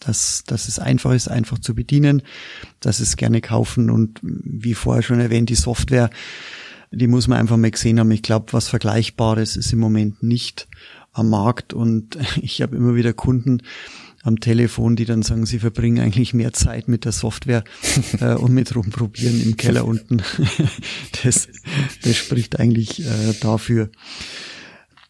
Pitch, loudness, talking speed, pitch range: 115 Hz, -19 LUFS, 160 wpm, 115-120 Hz